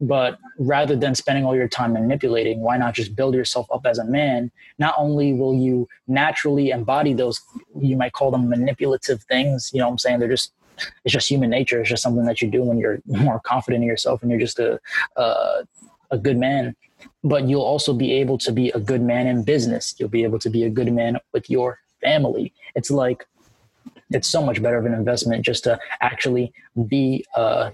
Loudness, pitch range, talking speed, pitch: -21 LUFS, 120-135 Hz, 215 wpm, 125 Hz